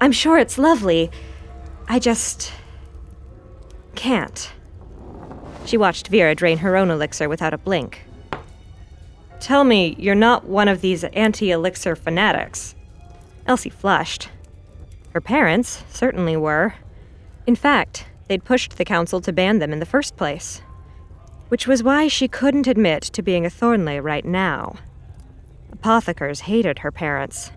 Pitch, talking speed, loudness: 165 Hz, 135 wpm, -19 LUFS